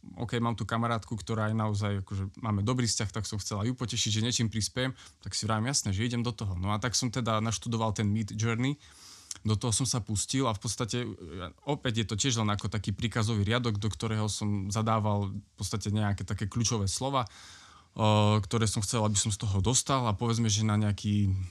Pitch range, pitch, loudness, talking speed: 105-120 Hz, 110 Hz, -30 LUFS, 210 wpm